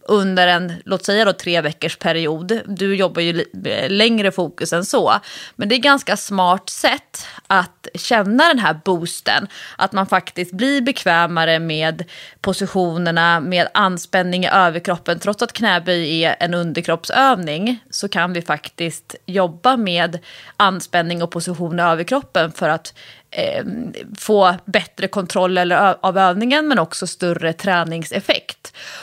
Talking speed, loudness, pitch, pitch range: 140 wpm, -17 LUFS, 180 Hz, 170-205 Hz